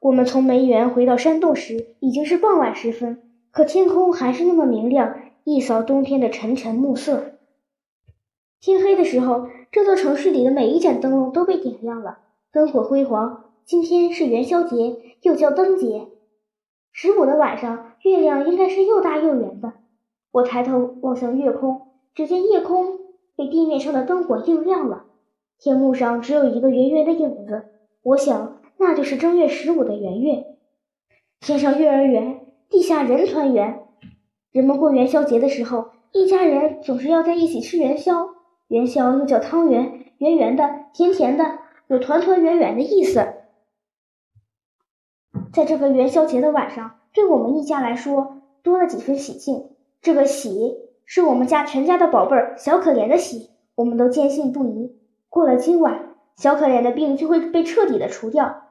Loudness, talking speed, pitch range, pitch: -19 LUFS, 250 characters per minute, 245-330 Hz, 280 Hz